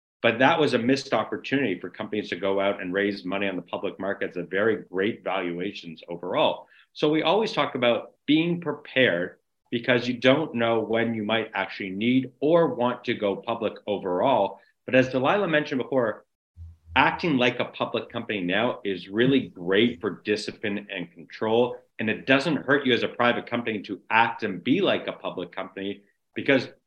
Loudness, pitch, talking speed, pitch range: -25 LUFS, 115 Hz, 180 wpm, 100-130 Hz